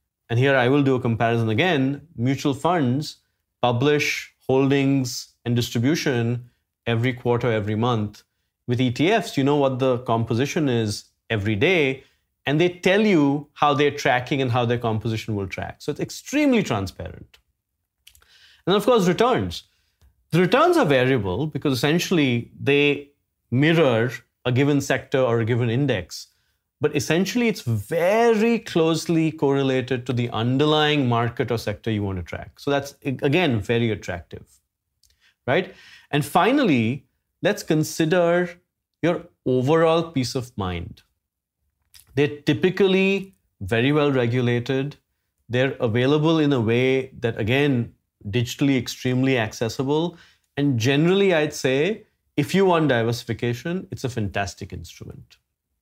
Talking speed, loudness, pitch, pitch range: 130 wpm, -22 LUFS, 130 Hz, 115-150 Hz